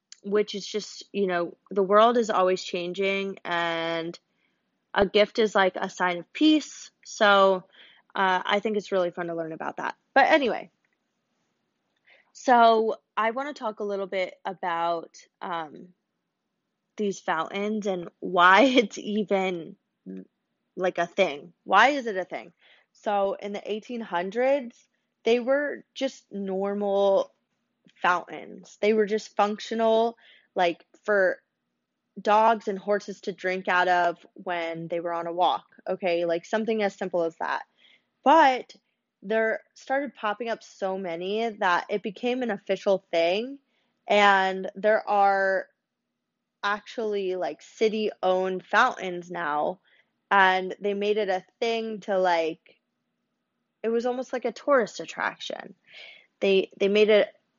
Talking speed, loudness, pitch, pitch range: 135 wpm, -25 LUFS, 200 Hz, 185-220 Hz